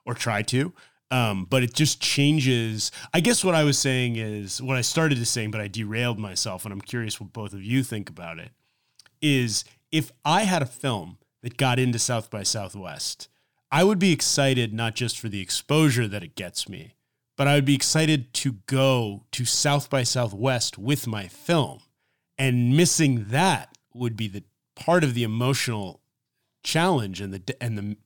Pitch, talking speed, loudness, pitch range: 125 Hz, 190 wpm, -24 LUFS, 110-140 Hz